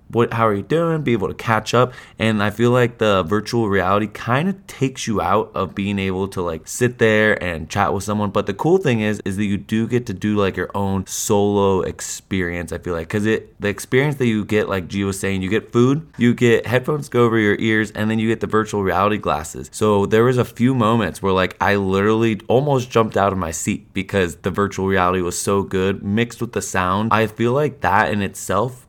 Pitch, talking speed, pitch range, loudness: 105 Hz, 240 wpm, 95-115 Hz, -19 LUFS